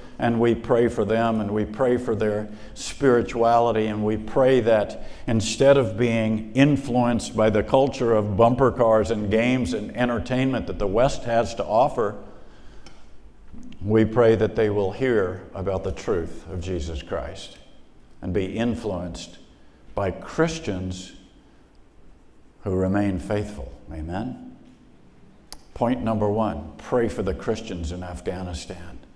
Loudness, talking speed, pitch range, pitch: -23 LUFS, 135 wpm, 95-115 Hz, 110 Hz